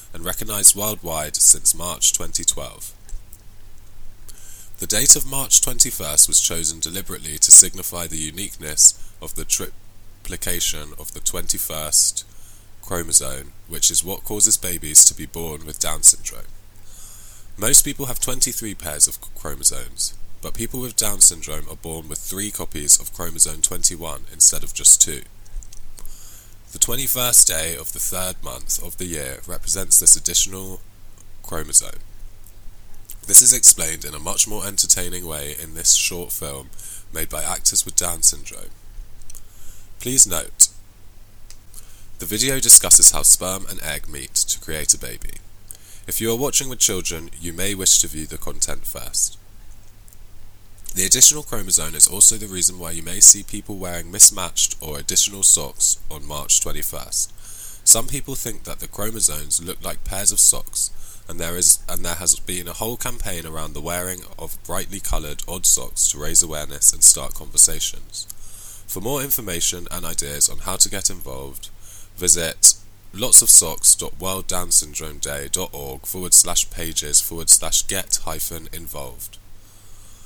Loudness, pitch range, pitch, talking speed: -15 LUFS, 85-100 Hz, 95 Hz, 145 wpm